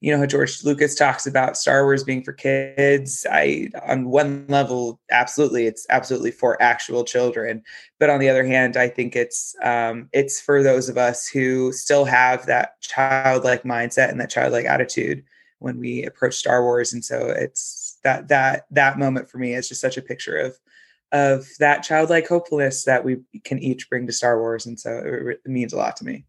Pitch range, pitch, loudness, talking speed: 125-140 Hz, 130 Hz, -20 LUFS, 200 wpm